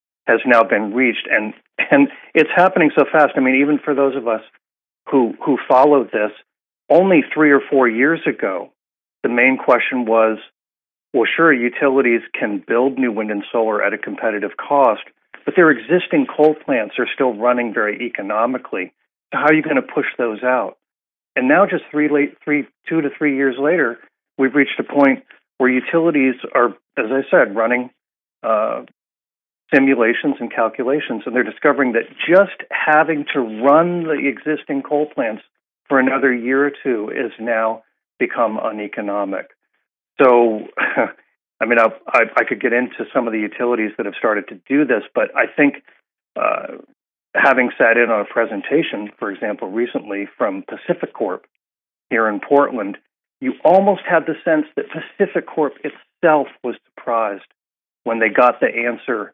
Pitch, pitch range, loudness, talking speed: 135 Hz, 115-150 Hz, -17 LUFS, 165 wpm